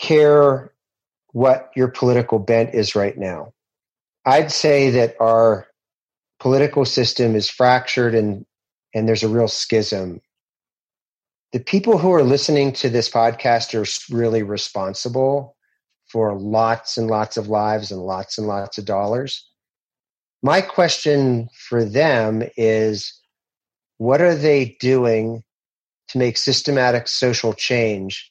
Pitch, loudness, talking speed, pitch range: 115 Hz, -18 LUFS, 125 wpm, 110-130 Hz